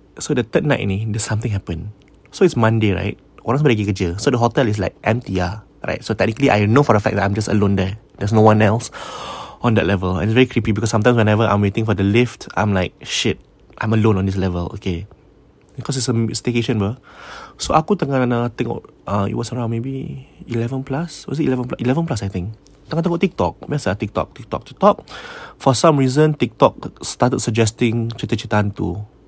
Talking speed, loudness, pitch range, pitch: 200 wpm, -18 LUFS, 100-130 Hz, 115 Hz